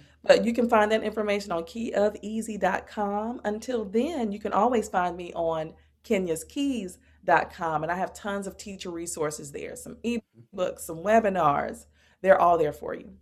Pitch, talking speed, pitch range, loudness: 205 Hz, 155 wpm, 175-225 Hz, -27 LUFS